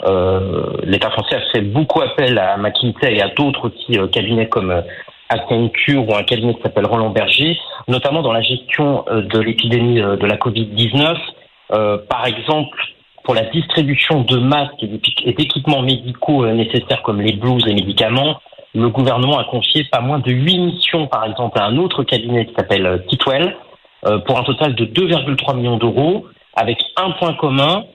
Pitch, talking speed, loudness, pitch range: 125 Hz, 190 wpm, -15 LUFS, 110-145 Hz